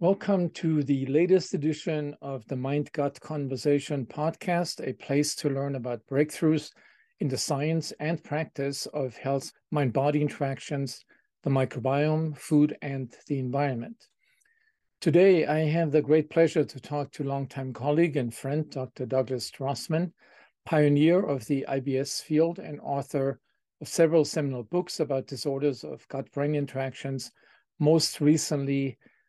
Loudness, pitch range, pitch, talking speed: -28 LUFS, 135-160 Hz, 145 Hz, 135 wpm